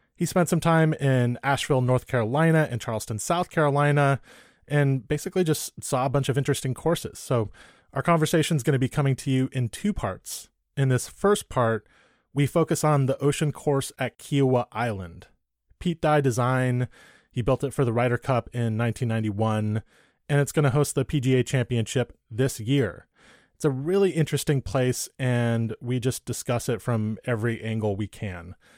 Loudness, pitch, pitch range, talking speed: -25 LUFS, 130 Hz, 120-150 Hz, 175 wpm